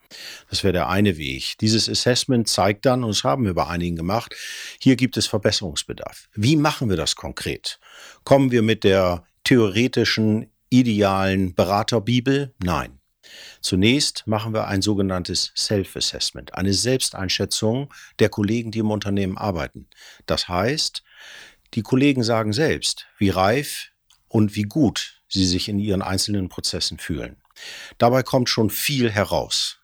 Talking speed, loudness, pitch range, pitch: 140 wpm, -21 LUFS, 95-120 Hz, 105 Hz